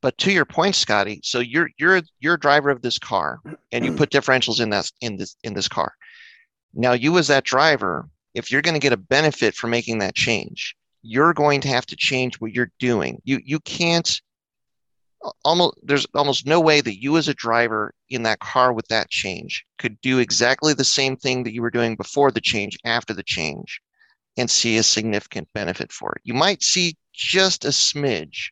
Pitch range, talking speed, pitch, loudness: 115-150 Hz, 205 wpm, 130 Hz, -20 LUFS